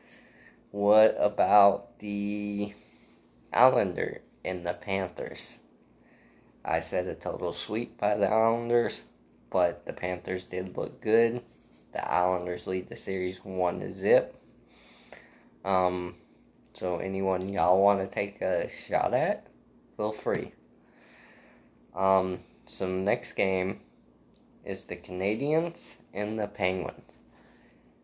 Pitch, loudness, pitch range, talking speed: 95 Hz, -29 LUFS, 90-105 Hz, 110 wpm